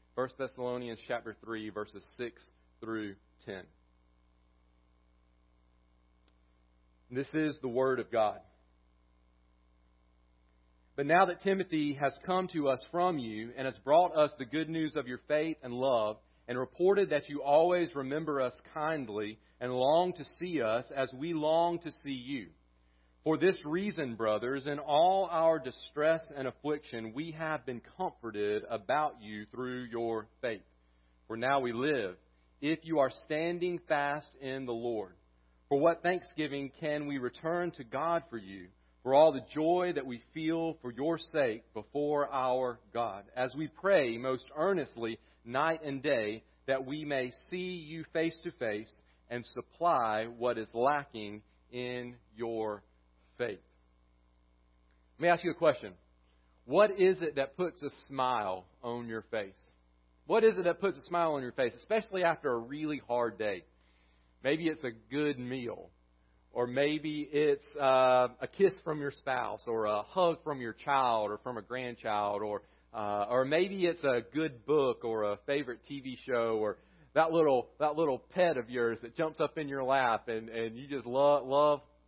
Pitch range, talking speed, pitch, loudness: 105-155 Hz, 165 wpm, 130 Hz, -33 LUFS